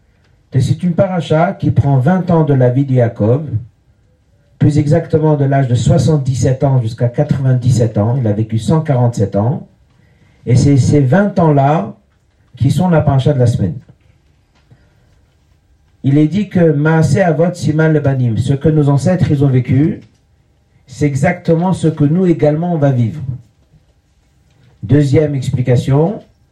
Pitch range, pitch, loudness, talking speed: 120-155 Hz, 140 Hz, -13 LUFS, 150 wpm